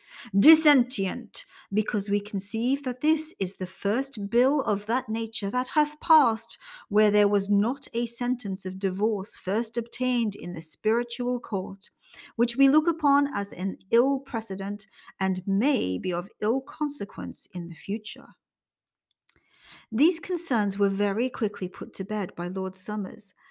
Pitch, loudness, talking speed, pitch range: 220 Hz, -26 LUFS, 150 wpm, 200-255 Hz